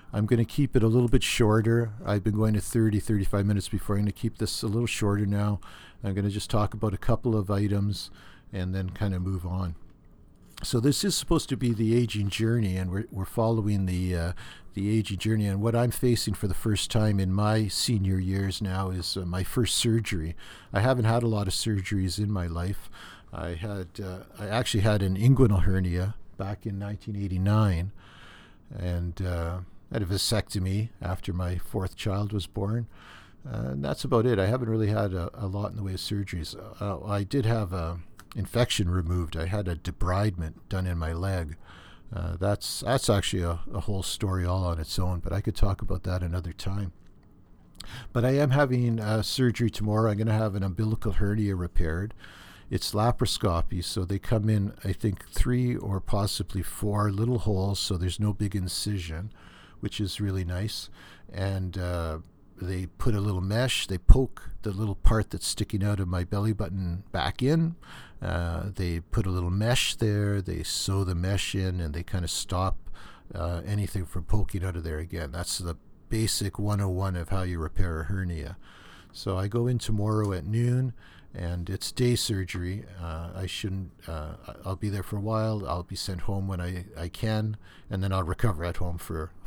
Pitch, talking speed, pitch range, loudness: 100 Hz, 195 wpm, 90-110 Hz, -28 LUFS